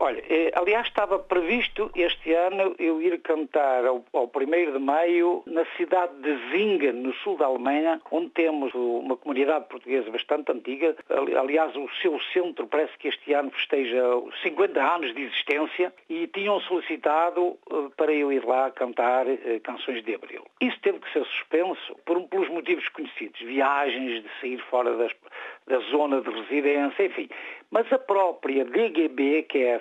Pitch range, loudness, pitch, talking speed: 135-195 Hz, -25 LUFS, 160 Hz, 160 wpm